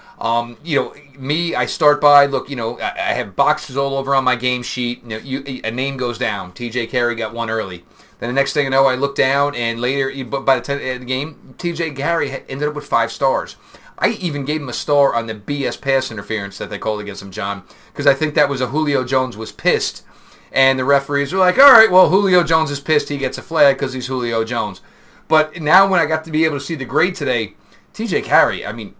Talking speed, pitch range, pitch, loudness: 250 wpm, 125-150 Hz, 135 Hz, -18 LUFS